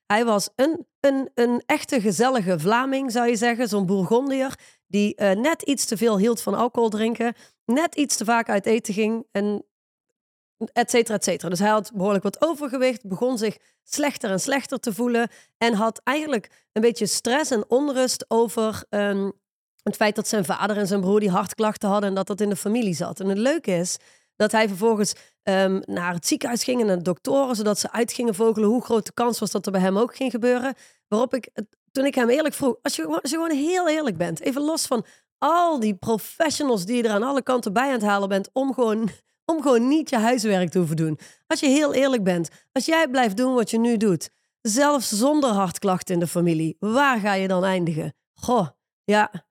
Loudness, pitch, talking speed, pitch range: -23 LUFS, 230 Hz, 215 wpm, 205-260 Hz